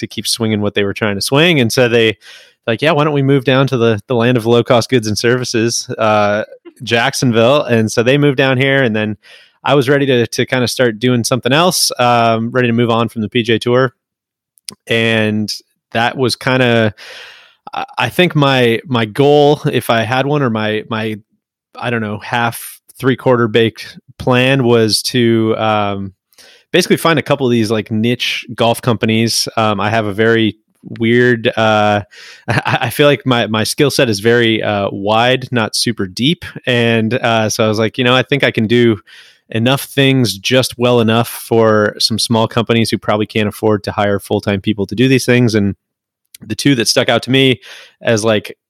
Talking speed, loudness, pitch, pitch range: 200 wpm, -13 LUFS, 115 Hz, 110-130 Hz